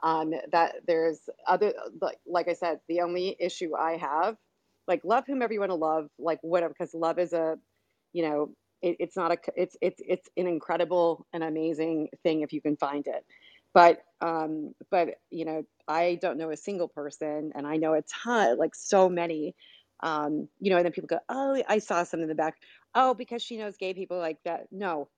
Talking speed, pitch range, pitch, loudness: 205 wpm, 160-185 Hz, 170 Hz, -29 LUFS